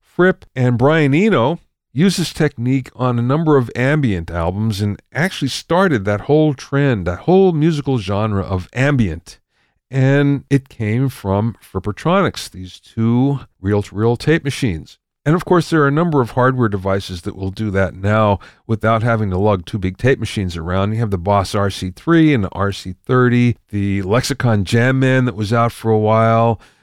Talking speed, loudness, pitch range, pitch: 170 wpm, -17 LUFS, 100-140 Hz, 115 Hz